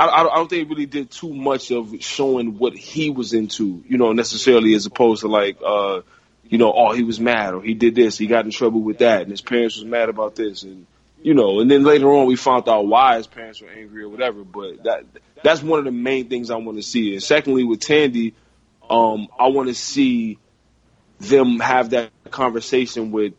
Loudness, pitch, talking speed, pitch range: -18 LUFS, 120 Hz, 230 wpm, 110-130 Hz